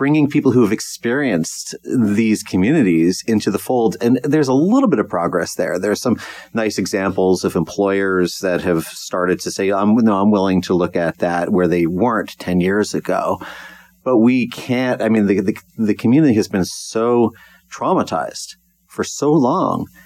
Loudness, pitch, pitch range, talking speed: -17 LUFS, 105 Hz, 95-120 Hz, 180 wpm